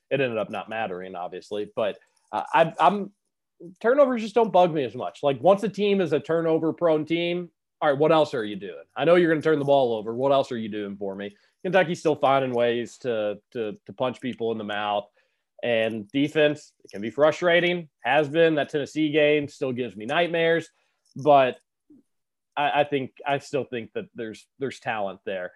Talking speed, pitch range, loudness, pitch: 205 wpm, 115-170 Hz, -24 LUFS, 150 Hz